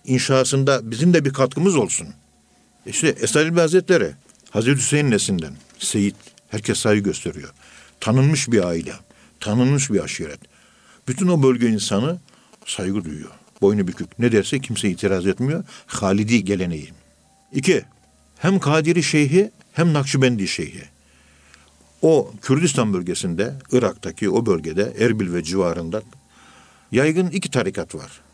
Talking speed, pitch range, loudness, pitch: 120 wpm, 95-140 Hz, -20 LUFS, 115 Hz